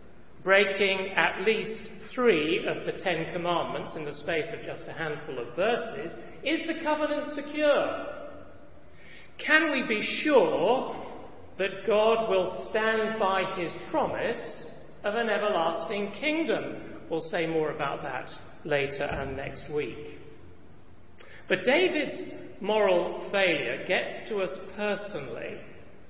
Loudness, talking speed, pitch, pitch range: -28 LUFS, 120 wpm, 210 Hz, 185-295 Hz